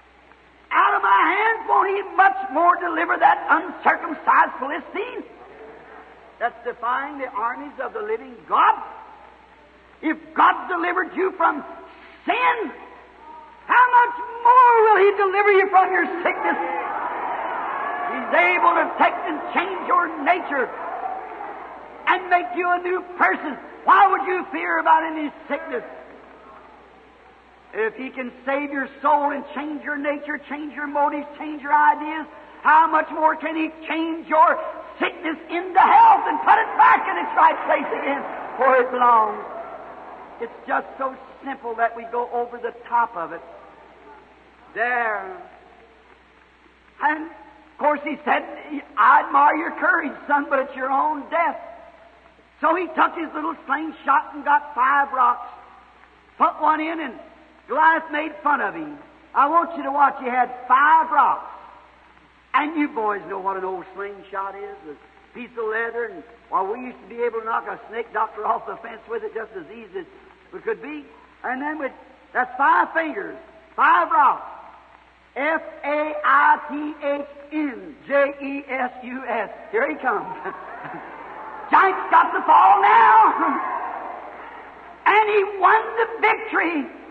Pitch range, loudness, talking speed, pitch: 275-365 Hz, -20 LUFS, 145 wpm, 310 Hz